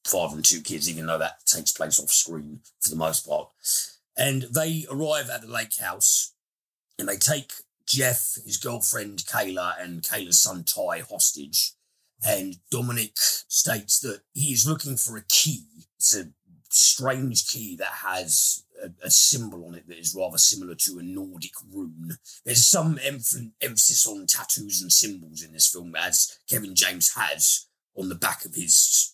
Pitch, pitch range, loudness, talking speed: 105 Hz, 85-130 Hz, -22 LUFS, 170 wpm